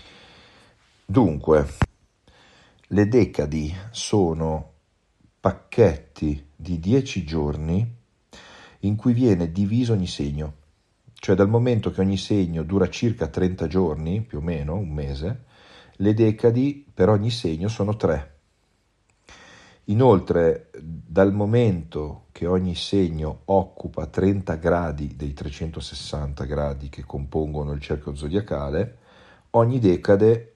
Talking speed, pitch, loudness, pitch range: 110 wpm, 90 Hz, -23 LUFS, 80-105 Hz